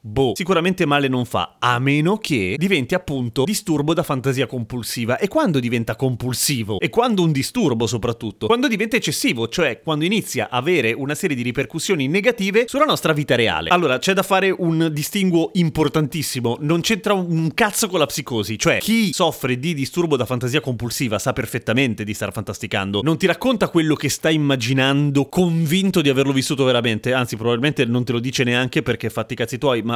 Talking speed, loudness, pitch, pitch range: 185 wpm, -19 LUFS, 140 Hz, 125-170 Hz